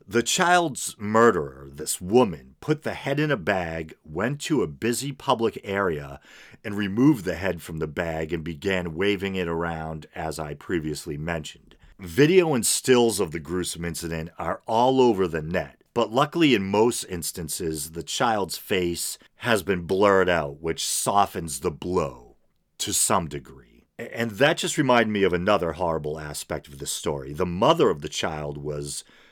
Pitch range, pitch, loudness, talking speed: 80-115 Hz, 90 Hz, -24 LUFS, 170 wpm